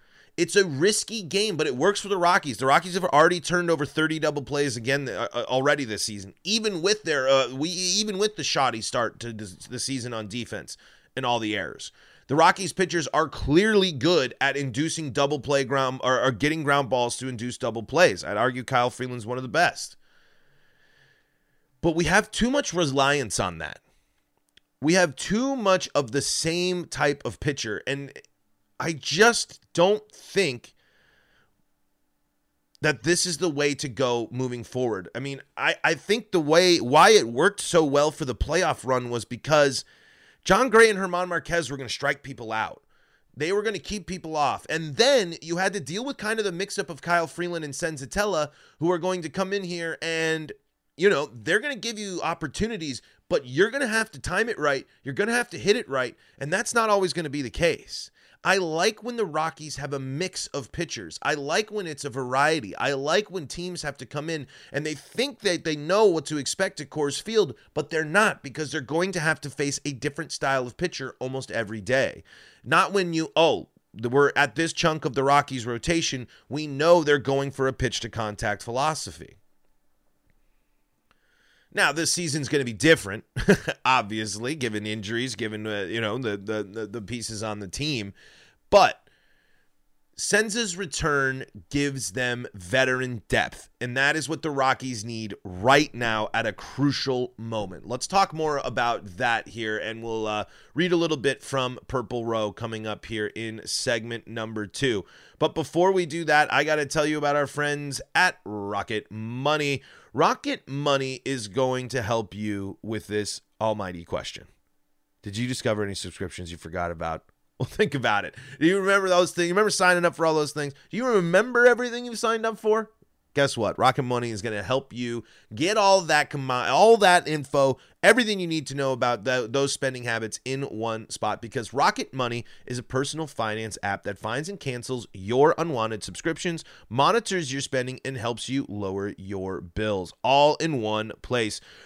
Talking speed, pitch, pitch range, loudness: 190 wpm, 140 Hz, 120-175 Hz, -25 LUFS